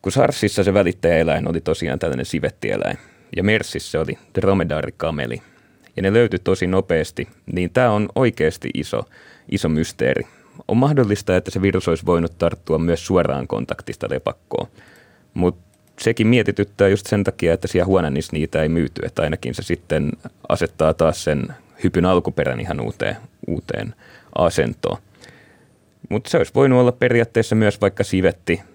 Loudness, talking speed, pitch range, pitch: -20 LUFS, 145 wpm, 85-110 Hz, 95 Hz